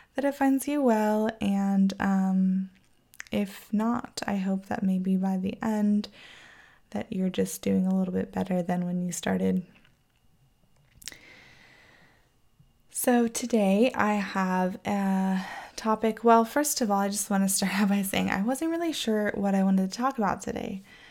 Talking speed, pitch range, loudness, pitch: 160 wpm, 190-225 Hz, -27 LUFS, 200 Hz